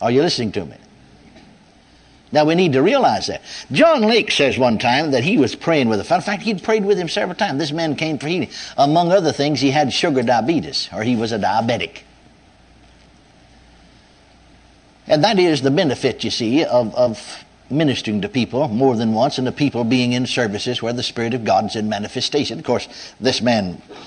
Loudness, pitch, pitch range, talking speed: -18 LUFS, 135 Hz, 120-165 Hz, 200 wpm